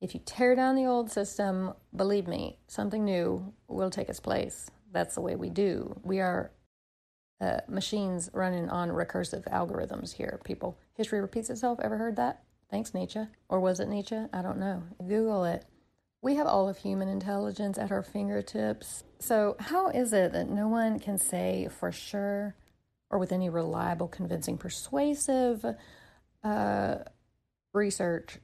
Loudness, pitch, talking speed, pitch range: -31 LUFS, 200 Hz, 160 wpm, 185-220 Hz